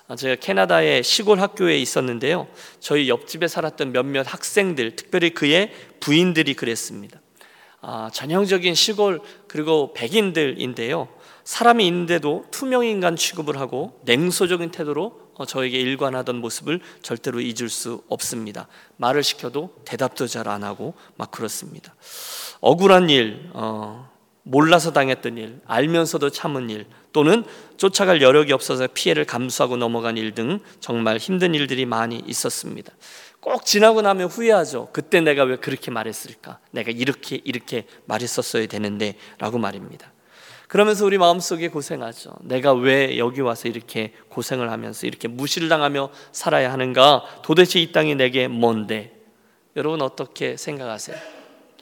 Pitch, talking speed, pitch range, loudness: 140 Hz, 330 characters per minute, 120-175 Hz, -20 LUFS